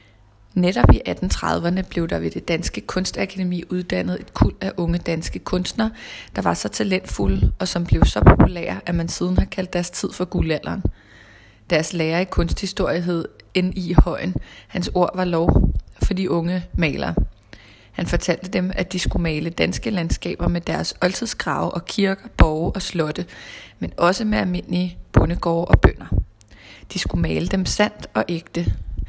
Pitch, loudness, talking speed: 170 Hz, -21 LUFS, 165 wpm